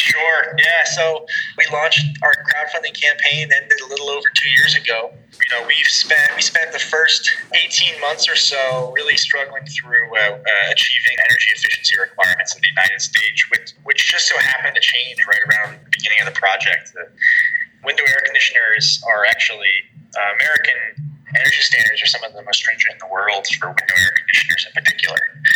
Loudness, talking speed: -14 LUFS, 185 wpm